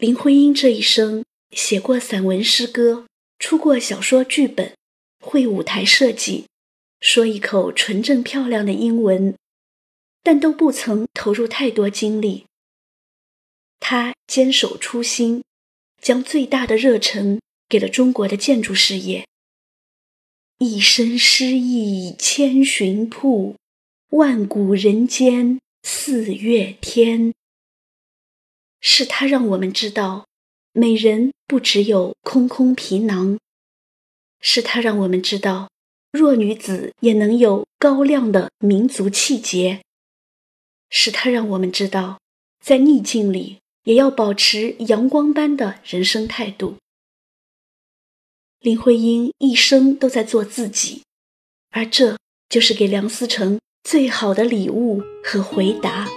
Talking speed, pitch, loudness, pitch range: 175 characters per minute, 230 Hz, -17 LUFS, 205-255 Hz